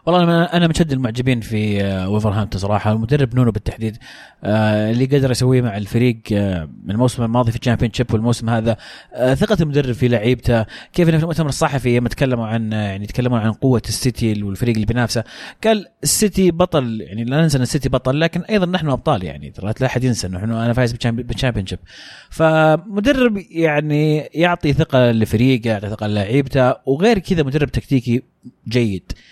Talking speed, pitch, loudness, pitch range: 160 wpm, 125 Hz, -18 LUFS, 110-150 Hz